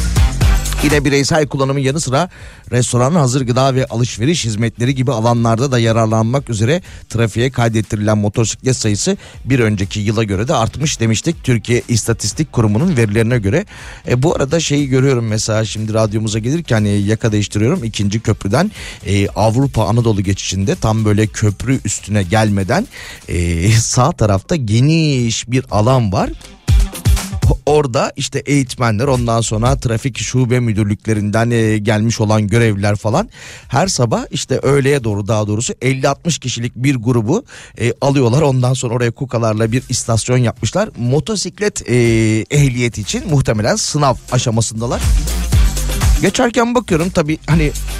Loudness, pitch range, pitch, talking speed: -15 LUFS, 110-135 Hz, 115 Hz, 130 wpm